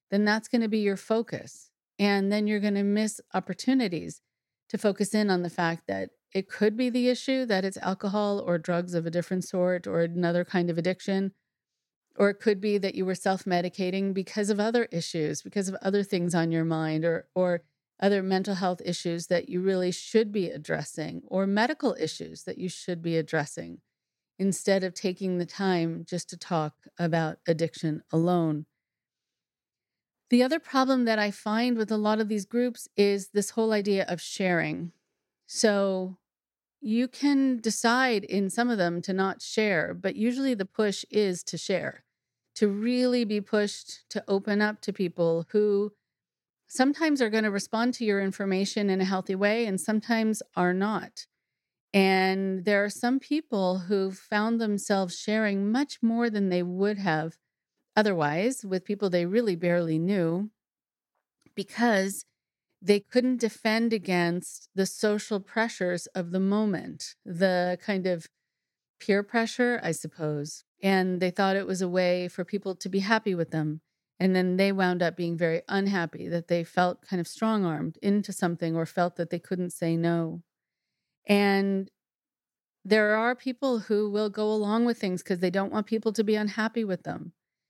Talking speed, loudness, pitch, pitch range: 170 wpm, -27 LUFS, 195 Hz, 175-215 Hz